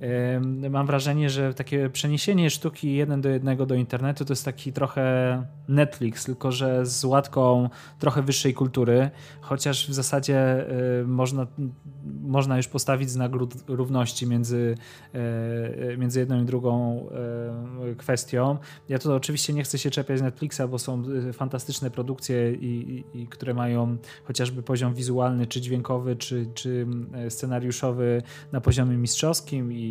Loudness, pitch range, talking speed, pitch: -26 LUFS, 125-140 Hz, 130 wpm, 130 Hz